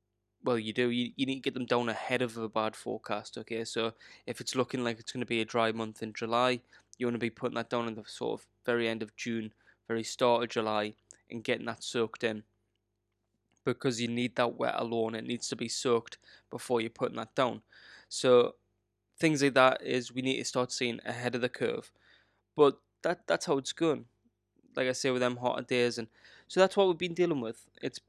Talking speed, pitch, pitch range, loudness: 220 wpm, 120 Hz, 110-125 Hz, -32 LUFS